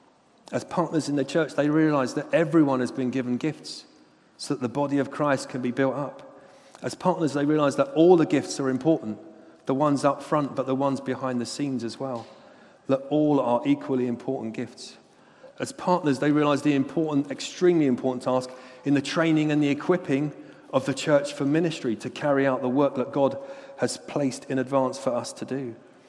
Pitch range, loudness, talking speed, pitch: 130-150 Hz, -25 LUFS, 200 wpm, 140 Hz